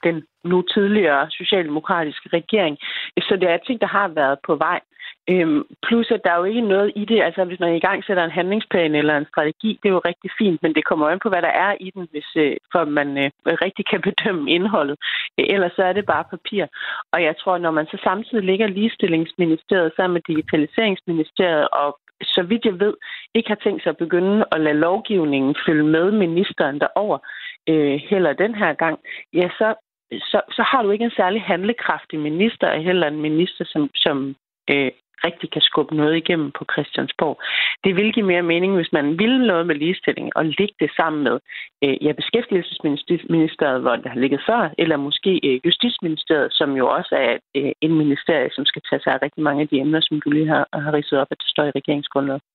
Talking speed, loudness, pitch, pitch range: 210 wpm, -20 LUFS, 170 Hz, 150-195 Hz